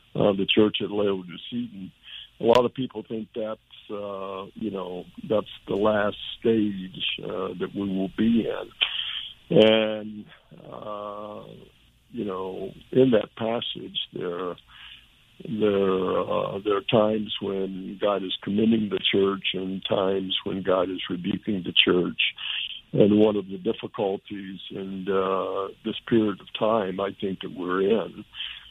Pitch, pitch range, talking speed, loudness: 100 Hz, 95-110 Hz, 140 wpm, -25 LUFS